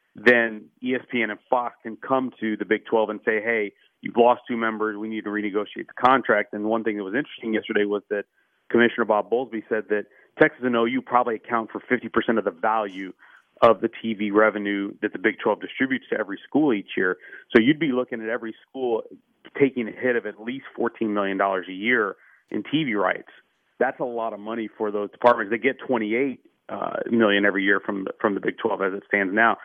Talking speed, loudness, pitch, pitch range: 215 wpm, -24 LUFS, 110 Hz, 105-120 Hz